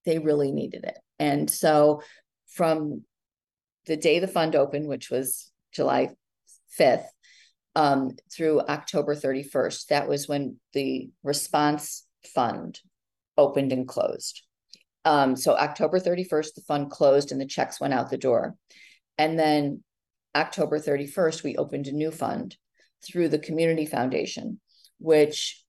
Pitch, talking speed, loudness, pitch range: 150 Hz, 135 wpm, -25 LUFS, 140-160 Hz